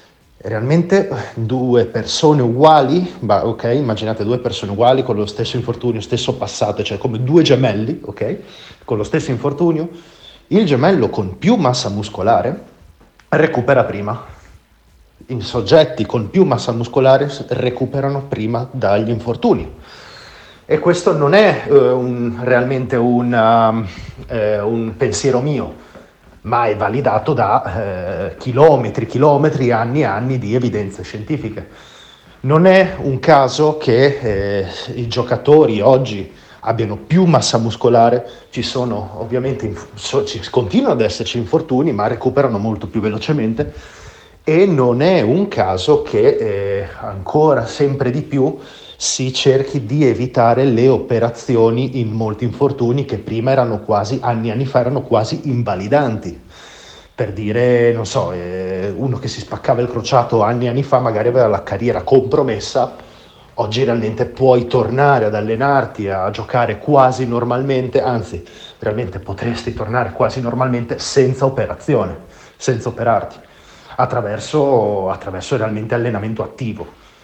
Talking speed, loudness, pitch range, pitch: 130 wpm, -16 LUFS, 110-135 Hz, 120 Hz